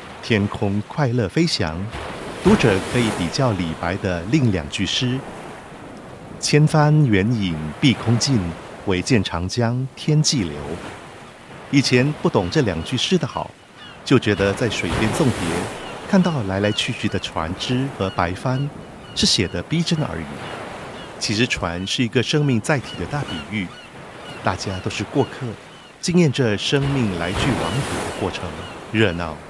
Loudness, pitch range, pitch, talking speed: -21 LUFS, 95-140 Hz, 120 Hz, 210 characters per minute